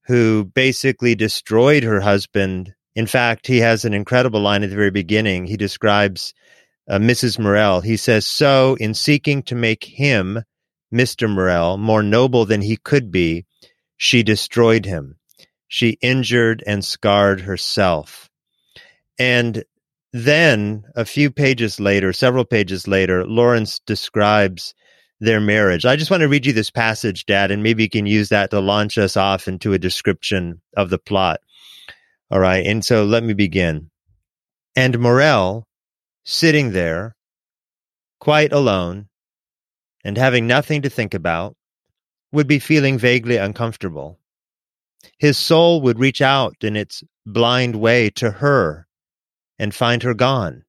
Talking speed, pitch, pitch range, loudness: 145 wpm, 110 Hz, 100-125 Hz, -17 LUFS